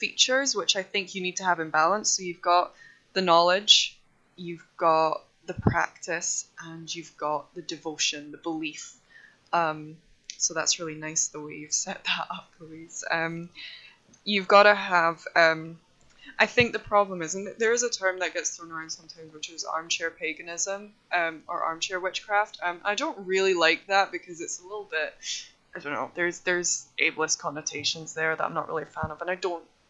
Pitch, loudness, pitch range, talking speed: 170 Hz, -26 LUFS, 160-190 Hz, 195 wpm